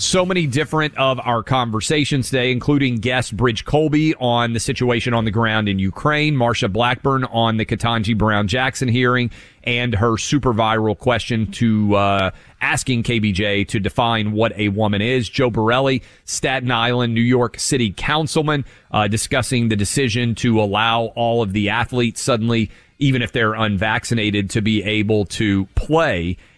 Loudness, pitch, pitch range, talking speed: -18 LUFS, 115 Hz, 110-130 Hz, 160 wpm